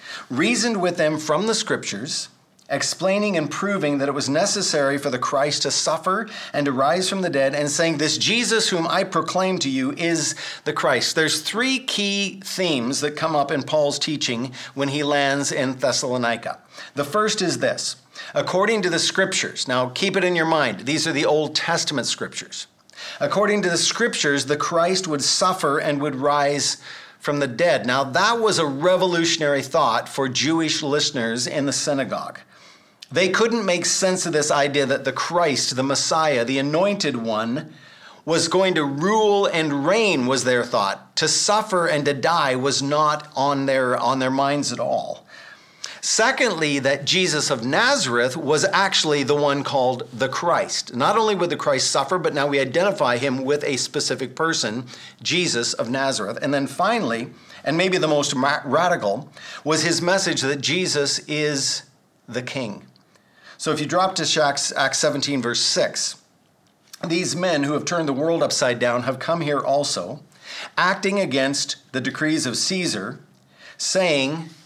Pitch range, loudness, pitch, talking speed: 140-175 Hz, -21 LUFS, 150 Hz, 170 wpm